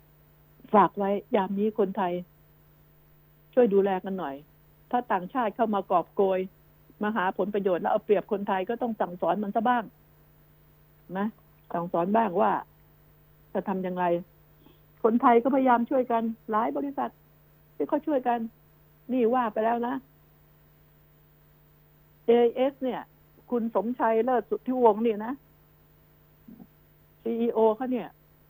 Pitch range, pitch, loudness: 155-235 Hz, 205 Hz, -27 LUFS